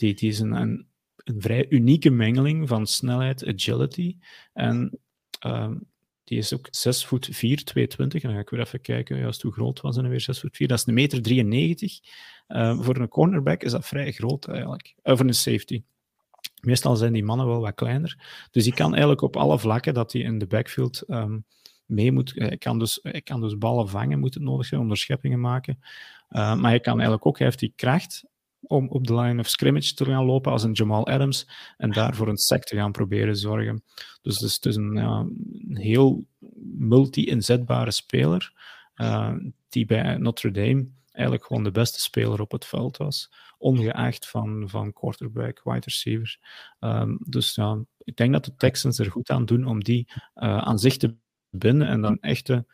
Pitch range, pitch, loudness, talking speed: 110-130 Hz, 120 Hz, -24 LUFS, 195 wpm